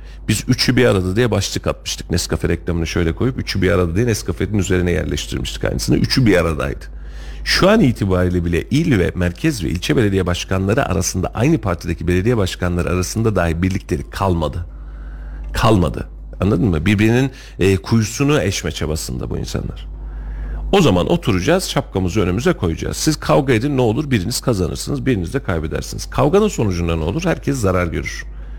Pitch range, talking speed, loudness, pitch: 85-120 Hz, 155 wpm, -18 LUFS, 95 Hz